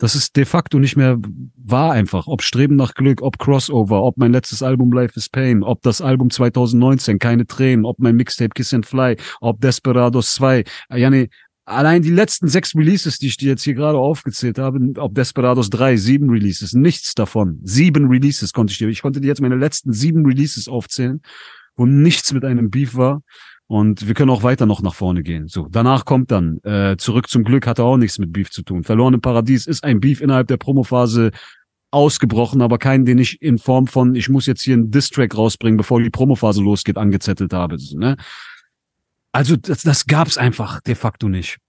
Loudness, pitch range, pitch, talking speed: -16 LUFS, 115-135 Hz, 125 Hz, 205 wpm